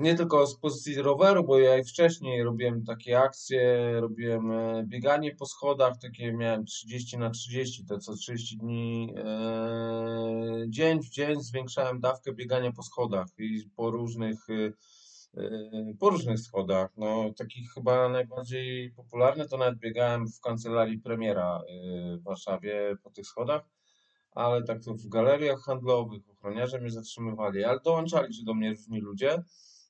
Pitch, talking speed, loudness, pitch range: 120 Hz, 145 wpm, -29 LUFS, 110-130 Hz